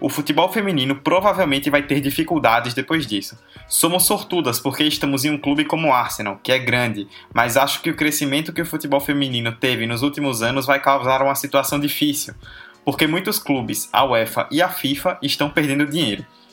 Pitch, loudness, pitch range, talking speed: 145 Hz, -19 LUFS, 135-155 Hz, 185 wpm